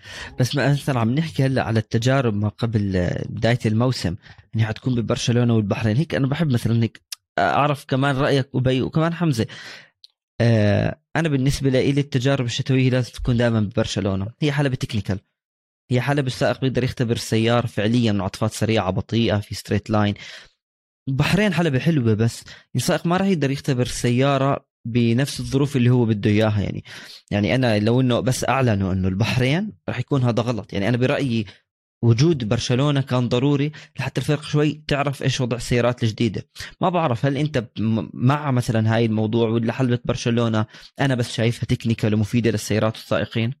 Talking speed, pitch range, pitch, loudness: 160 wpm, 110-135 Hz, 120 Hz, -21 LUFS